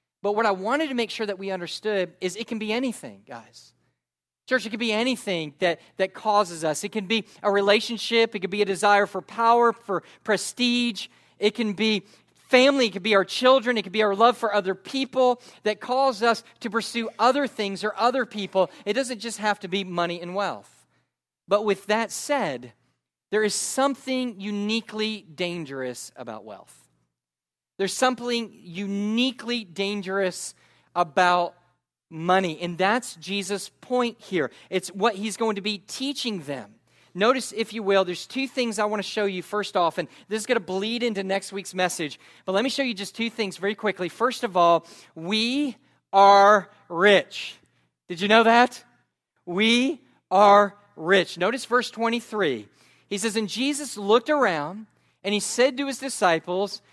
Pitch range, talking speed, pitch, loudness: 190-235 Hz, 175 wpm, 210 Hz, -24 LUFS